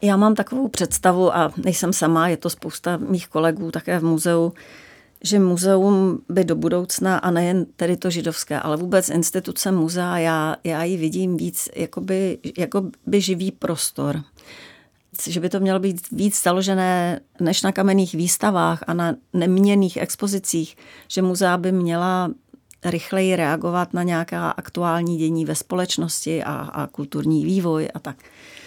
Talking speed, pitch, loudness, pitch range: 150 wpm, 175 Hz, -21 LUFS, 165-185 Hz